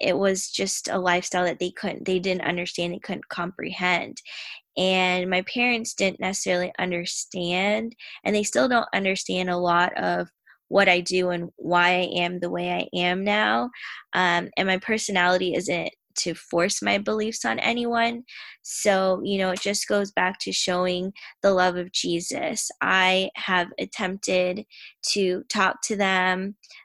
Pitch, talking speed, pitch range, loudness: 185 Hz, 160 wpm, 180-200 Hz, -24 LUFS